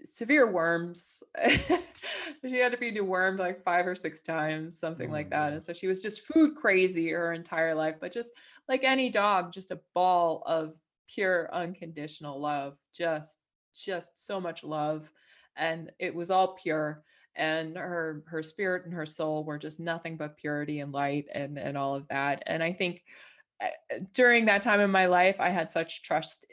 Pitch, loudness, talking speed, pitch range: 170 Hz, -29 LUFS, 180 wpm, 155-190 Hz